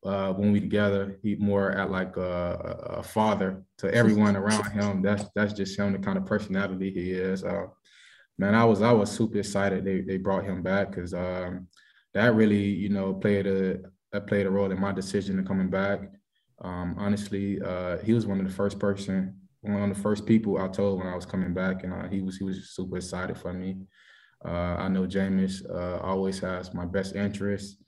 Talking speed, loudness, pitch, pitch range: 210 wpm, -28 LUFS, 95 Hz, 95-100 Hz